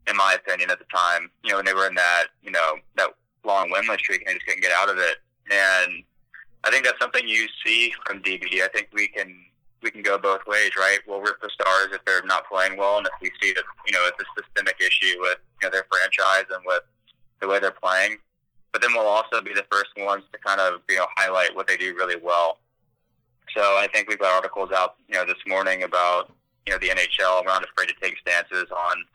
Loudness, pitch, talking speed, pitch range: -22 LUFS, 95 Hz, 245 wpm, 90-100 Hz